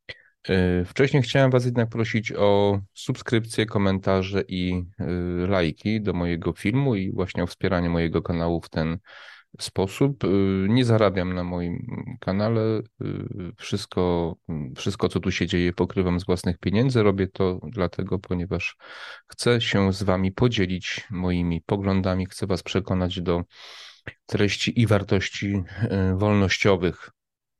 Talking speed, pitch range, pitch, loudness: 120 wpm, 90-110 Hz, 95 Hz, -24 LUFS